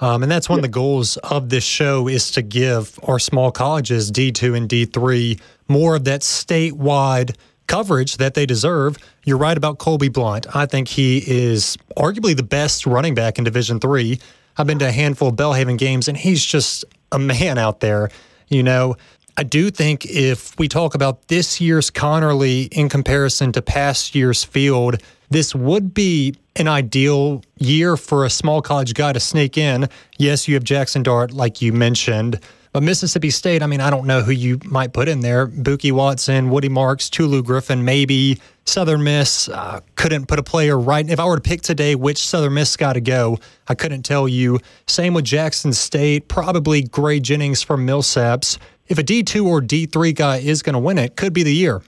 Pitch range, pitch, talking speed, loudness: 130-150 Hz, 140 Hz, 200 wpm, -17 LUFS